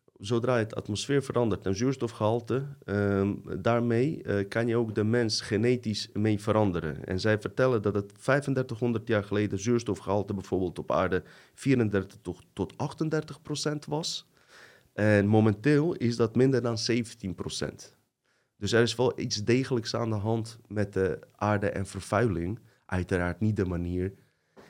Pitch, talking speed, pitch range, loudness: 110 Hz, 145 wpm, 100-120 Hz, -29 LUFS